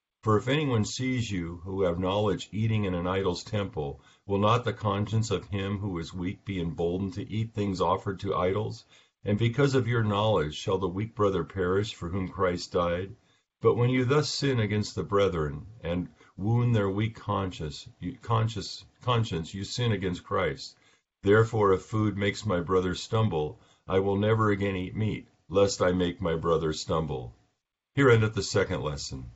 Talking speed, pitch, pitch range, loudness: 180 wpm, 100 Hz, 90-110 Hz, -28 LUFS